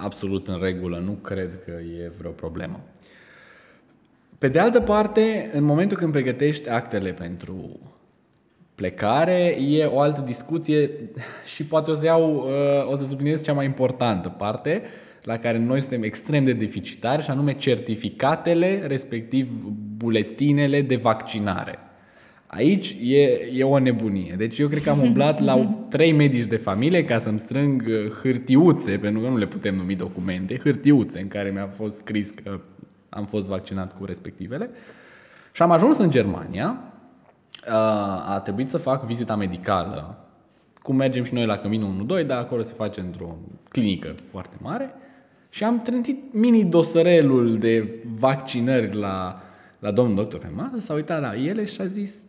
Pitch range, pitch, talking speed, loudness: 100-145 Hz, 120 Hz, 150 wpm, -22 LUFS